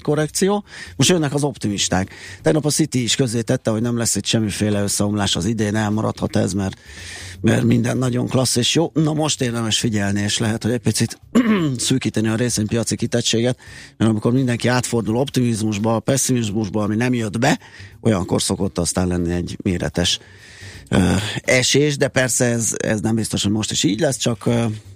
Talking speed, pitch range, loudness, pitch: 175 wpm, 105-125 Hz, -19 LUFS, 115 Hz